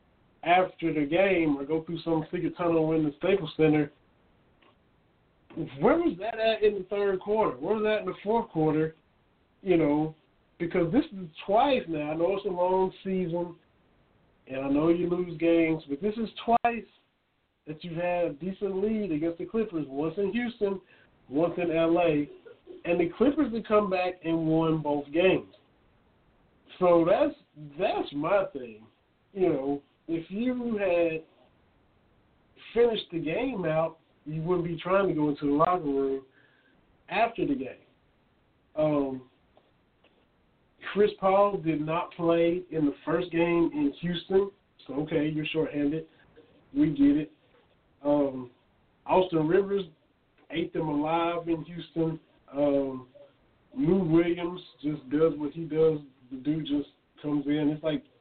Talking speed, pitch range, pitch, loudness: 150 wpm, 150-190 Hz, 165 Hz, -28 LUFS